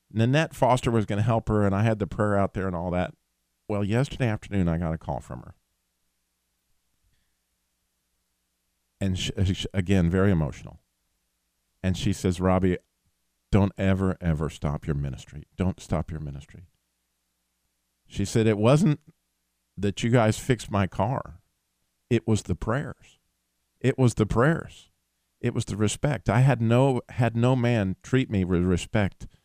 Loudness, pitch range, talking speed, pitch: -25 LUFS, 70-115 Hz, 155 wpm, 95 Hz